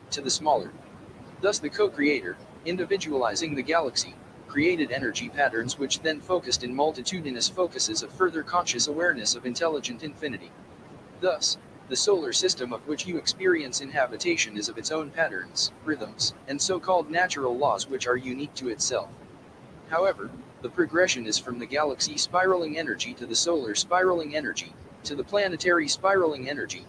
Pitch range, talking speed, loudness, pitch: 130-185 Hz, 155 wpm, -26 LUFS, 160 Hz